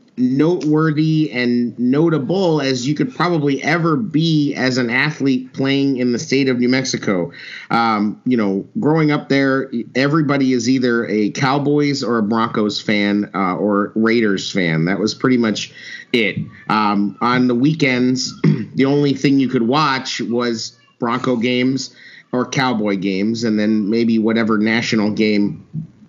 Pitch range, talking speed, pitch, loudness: 110-145 Hz, 150 wpm, 125 Hz, -17 LUFS